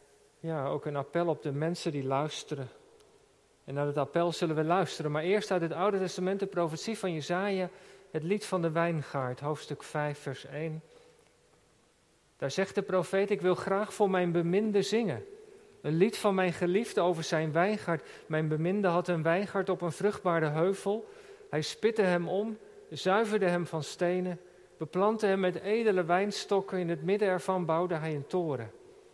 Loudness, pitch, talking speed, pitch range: -31 LUFS, 180 Hz, 175 wpm, 160-195 Hz